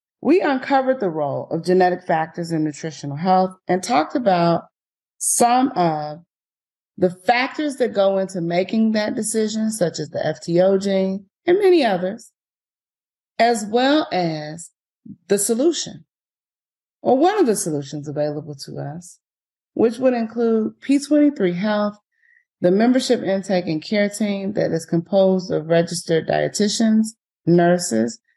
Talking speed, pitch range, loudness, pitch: 135 wpm, 170-235 Hz, -19 LUFS, 195 Hz